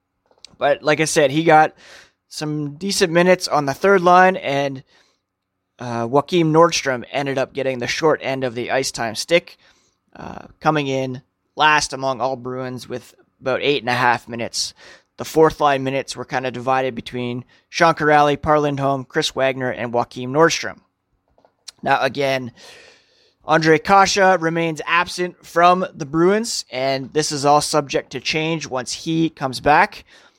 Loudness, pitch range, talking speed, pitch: -18 LUFS, 130-165 Hz, 155 wpm, 145 Hz